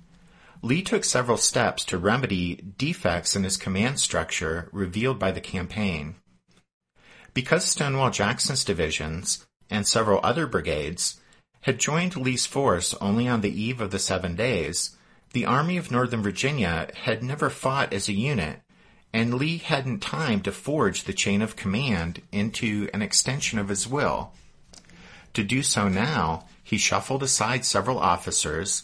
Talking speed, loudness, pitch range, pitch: 150 wpm, -25 LUFS, 95-130 Hz, 110 Hz